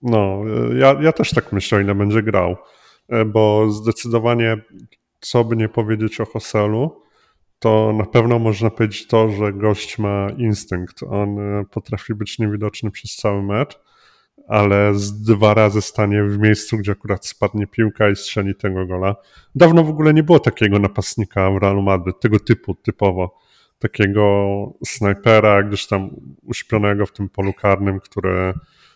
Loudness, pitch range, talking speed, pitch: -17 LUFS, 100-115 Hz, 150 wpm, 105 Hz